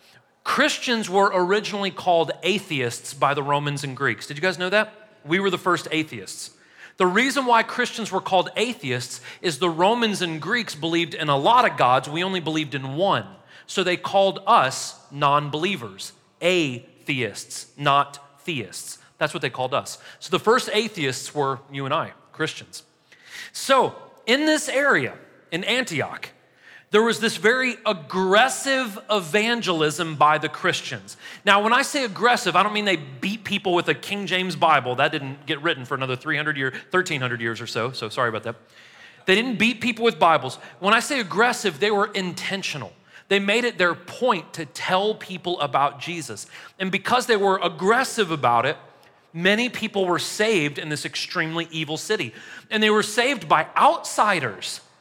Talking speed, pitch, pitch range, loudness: 170 wpm, 180 Hz, 145-215 Hz, -22 LUFS